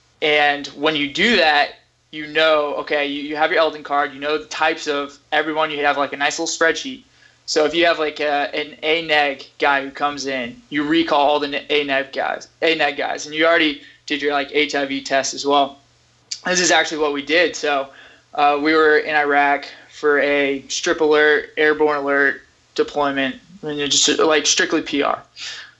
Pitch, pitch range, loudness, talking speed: 150 Hz, 140-155 Hz, -18 LUFS, 190 wpm